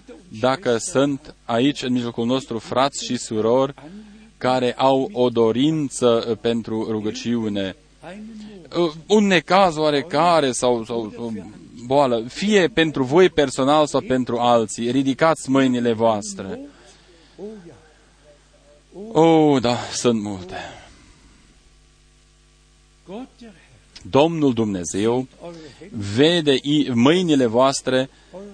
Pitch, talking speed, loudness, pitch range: 135 Hz, 85 wpm, -19 LUFS, 115-160 Hz